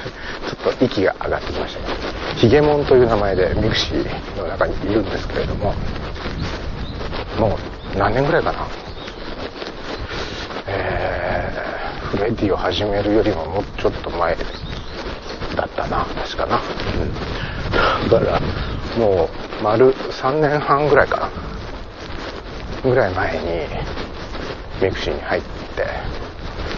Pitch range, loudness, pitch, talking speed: 85-105 Hz, -21 LUFS, 95 Hz, 225 characters per minute